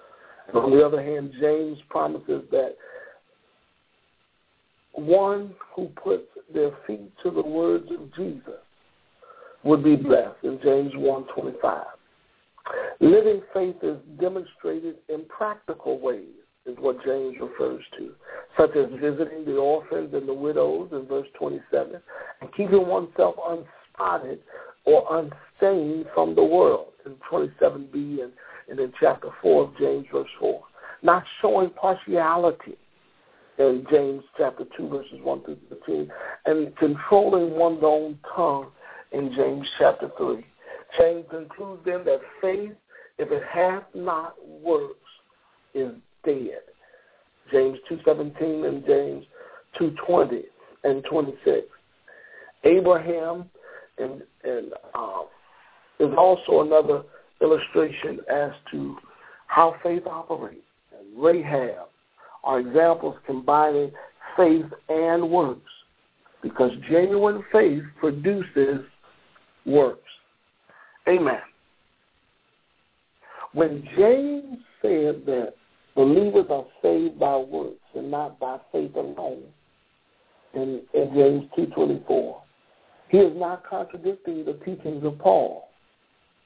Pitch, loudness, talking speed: 180 Hz, -23 LUFS, 110 wpm